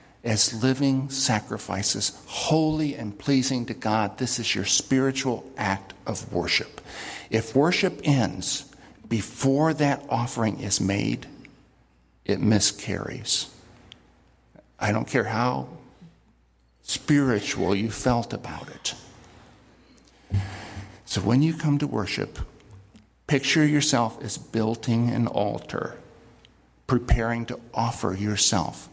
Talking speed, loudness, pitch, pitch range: 105 wpm, -25 LUFS, 115 Hz, 100-135 Hz